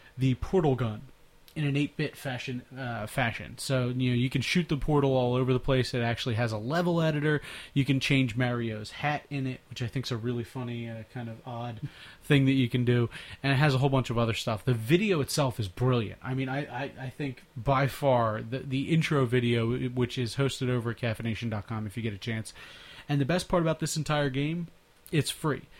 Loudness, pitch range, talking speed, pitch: -29 LUFS, 120-140 Hz, 225 wpm, 130 Hz